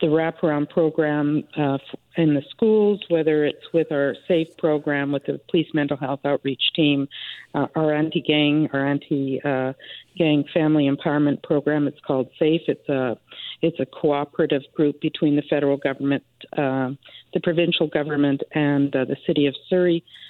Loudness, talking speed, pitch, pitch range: -22 LUFS, 150 wpm, 150 Hz, 140-160 Hz